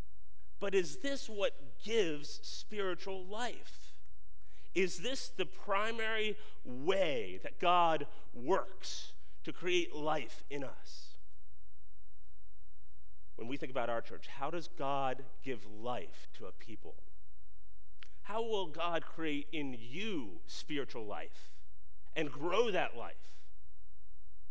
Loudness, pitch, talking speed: -38 LUFS, 120 Hz, 115 wpm